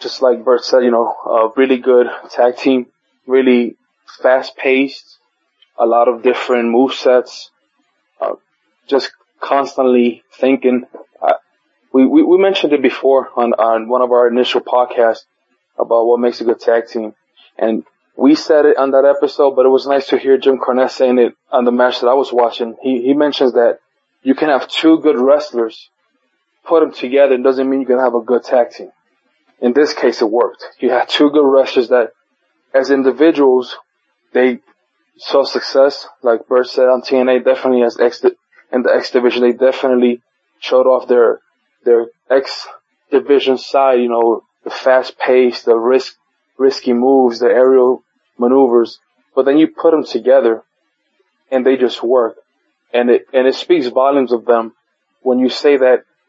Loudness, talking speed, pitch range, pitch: -13 LUFS, 175 wpm, 120-135 Hz, 130 Hz